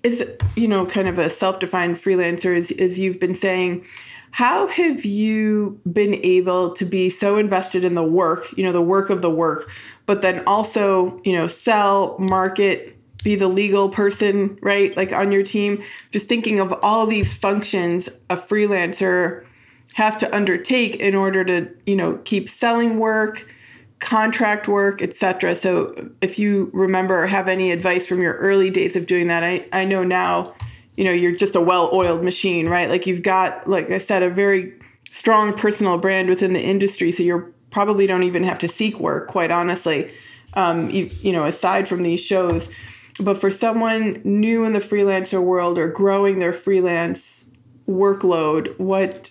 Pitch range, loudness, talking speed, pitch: 180-200 Hz, -19 LUFS, 175 wpm, 190 Hz